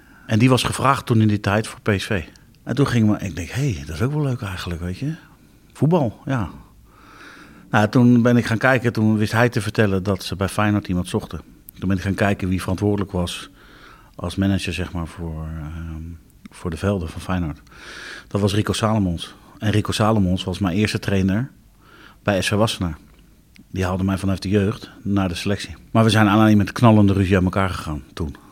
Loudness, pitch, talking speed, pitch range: -20 LUFS, 100 Hz, 210 wpm, 90-110 Hz